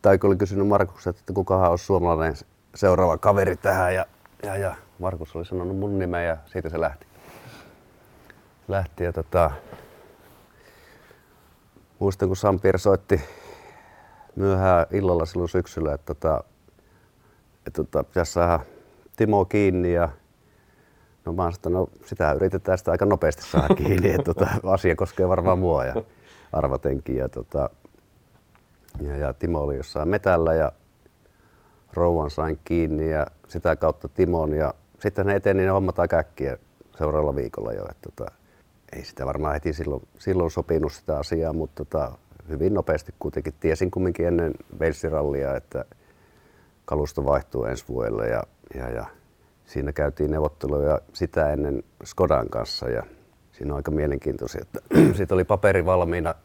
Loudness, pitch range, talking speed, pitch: -24 LUFS, 75-95 Hz, 140 wpm, 85 Hz